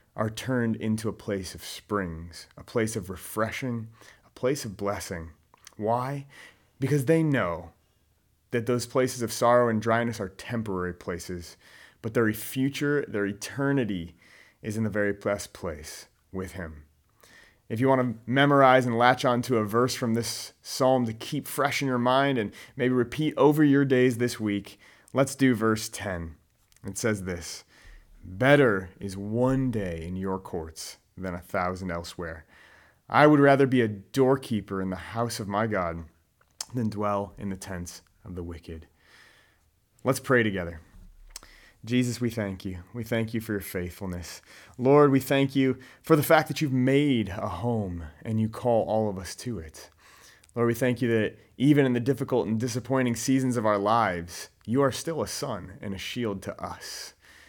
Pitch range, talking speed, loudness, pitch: 95-125 Hz, 175 wpm, -26 LUFS, 110 Hz